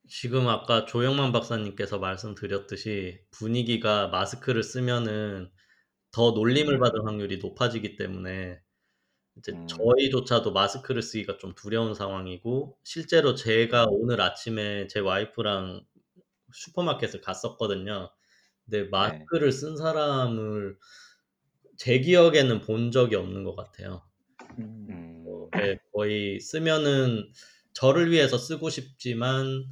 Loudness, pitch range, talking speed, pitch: -26 LUFS, 100-130 Hz, 265 characters per minute, 115 Hz